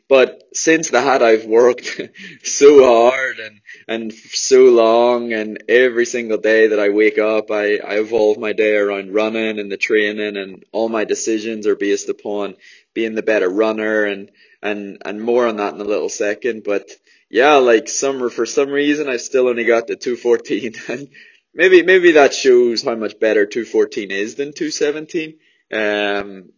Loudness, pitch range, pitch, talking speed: -16 LUFS, 105-145 Hz, 115 Hz, 180 wpm